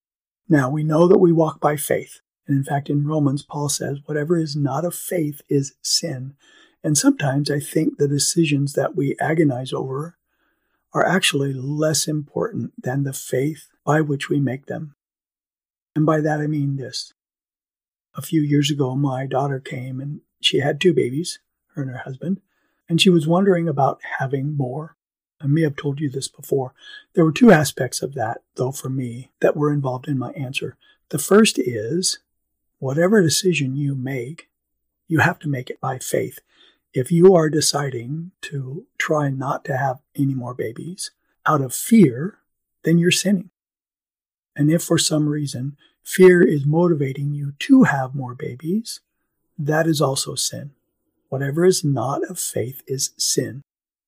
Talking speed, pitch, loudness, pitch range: 170 wpm, 150 Hz, -20 LUFS, 135-165 Hz